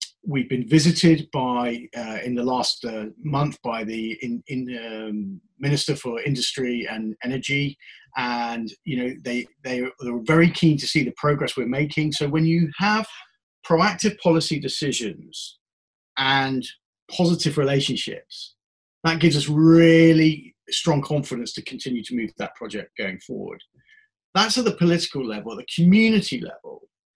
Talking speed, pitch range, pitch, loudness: 145 wpm, 125-165 Hz, 140 Hz, -22 LUFS